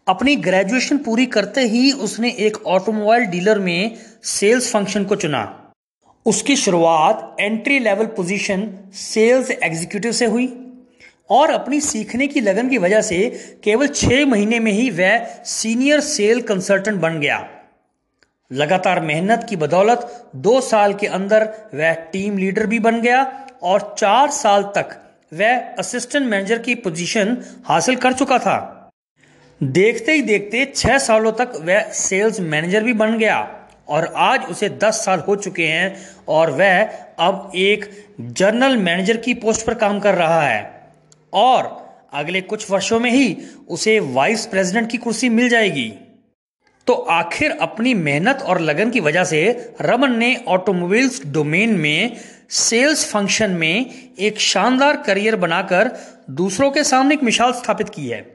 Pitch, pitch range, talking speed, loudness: 220 Hz, 195-245 Hz, 150 wpm, -17 LUFS